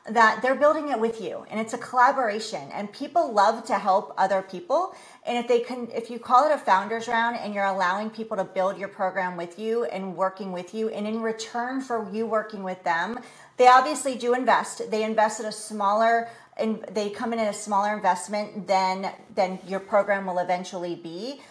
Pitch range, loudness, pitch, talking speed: 190-235 Hz, -25 LUFS, 215 Hz, 205 wpm